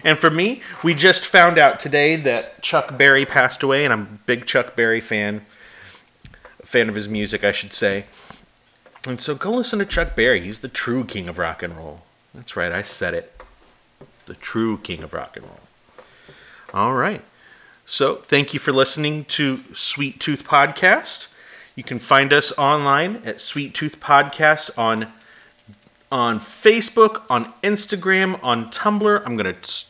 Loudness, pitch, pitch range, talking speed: -18 LUFS, 135 Hz, 110-160 Hz, 170 wpm